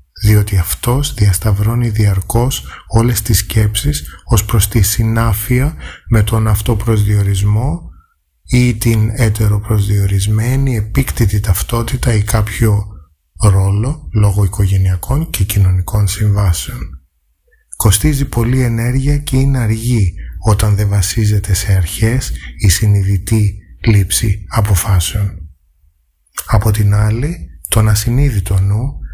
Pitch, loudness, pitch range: 105 Hz, -14 LUFS, 95-115 Hz